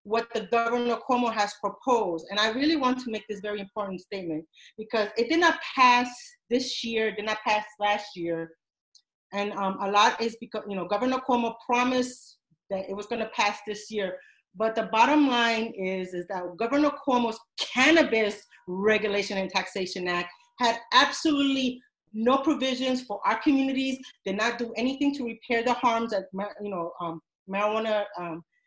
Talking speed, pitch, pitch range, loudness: 170 wpm, 220 Hz, 200-250 Hz, -26 LUFS